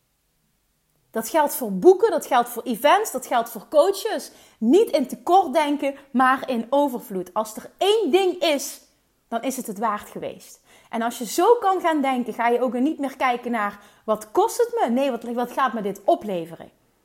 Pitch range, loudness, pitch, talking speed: 230-315 Hz, -22 LUFS, 260 Hz, 190 wpm